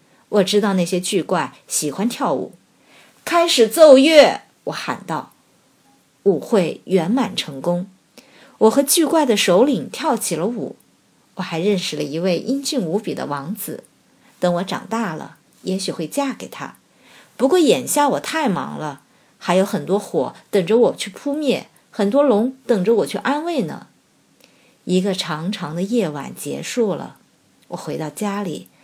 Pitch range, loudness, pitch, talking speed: 180-260 Hz, -19 LUFS, 205 Hz, 215 characters per minute